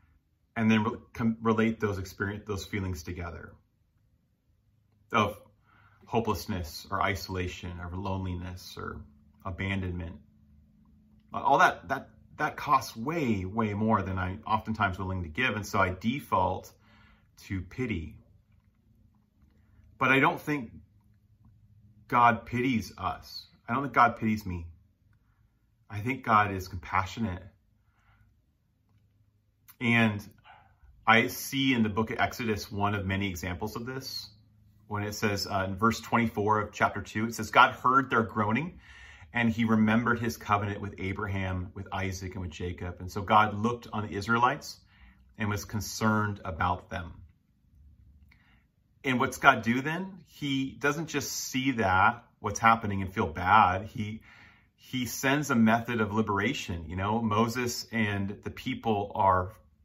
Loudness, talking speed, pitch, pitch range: -29 LUFS, 140 wpm, 105 Hz, 95-115 Hz